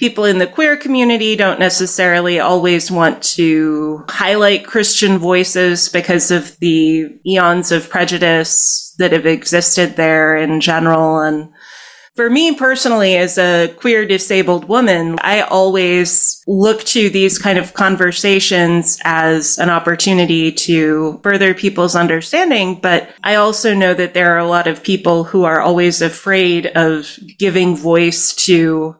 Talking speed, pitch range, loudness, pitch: 140 wpm, 165-195 Hz, -12 LUFS, 180 Hz